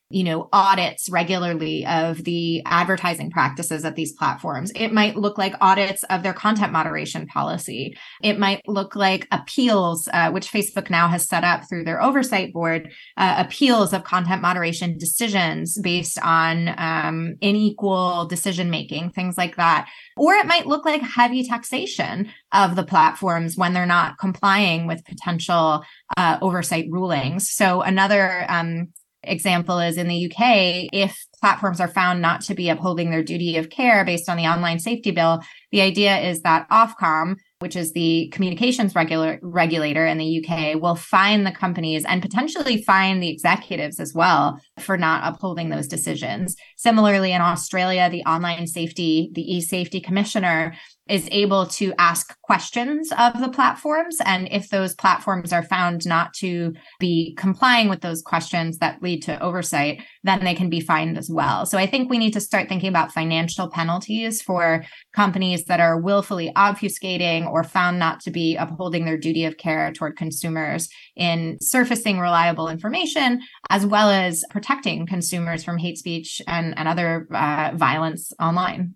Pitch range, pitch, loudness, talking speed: 165-195 Hz, 180 Hz, -20 LUFS, 165 wpm